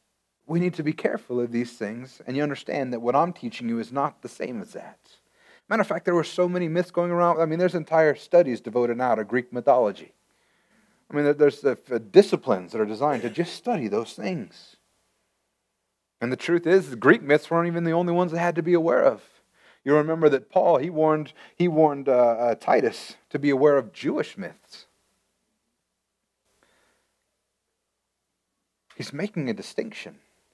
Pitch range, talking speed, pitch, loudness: 130-175 Hz, 185 wpm, 155 Hz, -24 LUFS